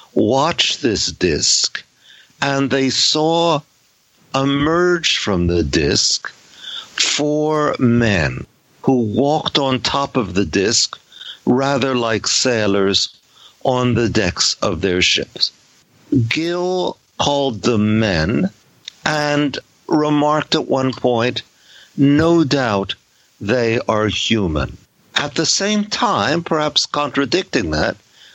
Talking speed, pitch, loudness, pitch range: 105 wpm, 135 Hz, -17 LUFS, 115-150 Hz